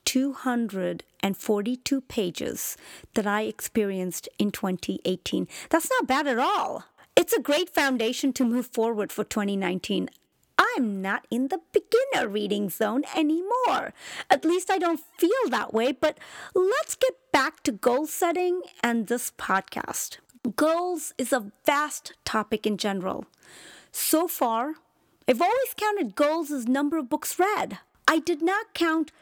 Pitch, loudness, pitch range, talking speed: 270 Hz, -26 LUFS, 220-335 Hz, 140 wpm